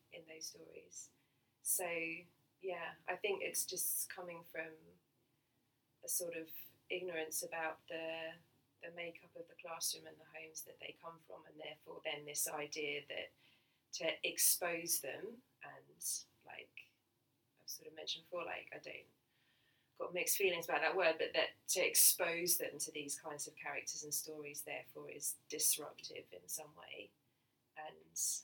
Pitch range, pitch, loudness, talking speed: 150-175 Hz, 160 Hz, -39 LUFS, 155 wpm